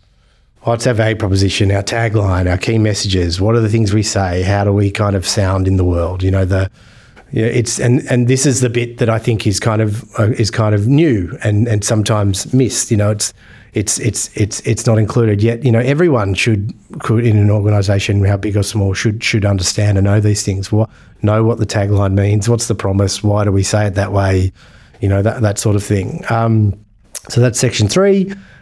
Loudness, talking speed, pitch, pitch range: -14 LUFS, 230 wpm, 105 Hz, 100-115 Hz